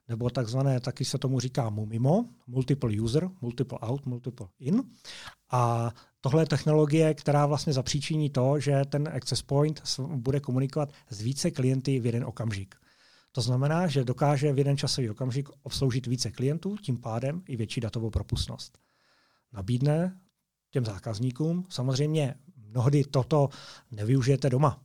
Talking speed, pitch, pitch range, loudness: 140 wpm, 135 Hz, 125-145 Hz, -28 LUFS